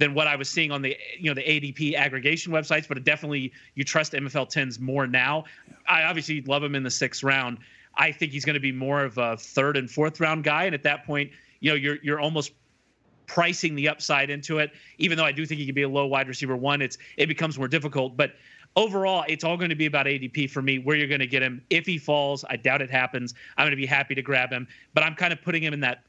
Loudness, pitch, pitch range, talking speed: -25 LUFS, 145 Hz, 135-155 Hz, 265 wpm